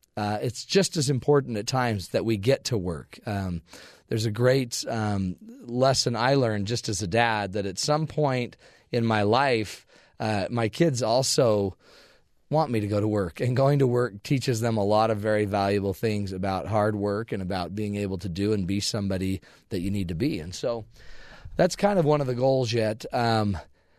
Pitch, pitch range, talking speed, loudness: 110 Hz, 100-125 Hz, 205 wpm, -26 LUFS